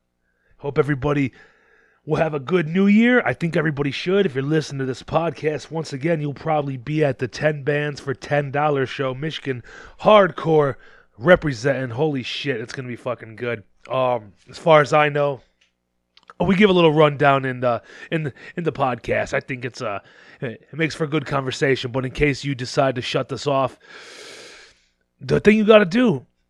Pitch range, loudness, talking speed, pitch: 130-165 Hz, -20 LUFS, 190 wpm, 145 Hz